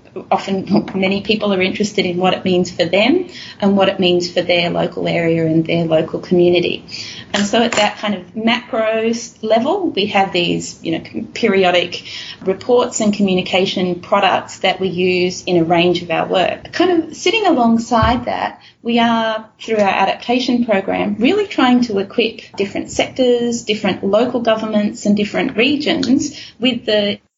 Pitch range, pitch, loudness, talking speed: 185-235 Hz, 210 Hz, -16 LUFS, 165 wpm